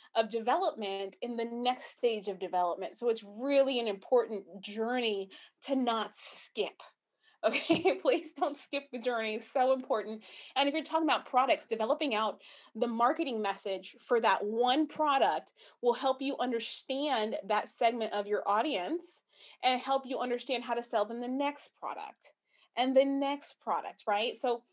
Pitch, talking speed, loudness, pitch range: 245 Hz, 165 wpm, -32 LUFS, 220-280 Hz